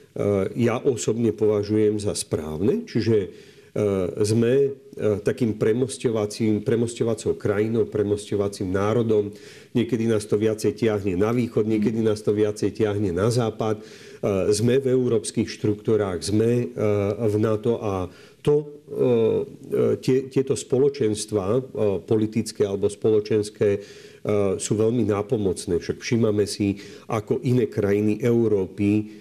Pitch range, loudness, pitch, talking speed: 105-115 Hz, -23 LUFS, 105 Hz, 105 wpm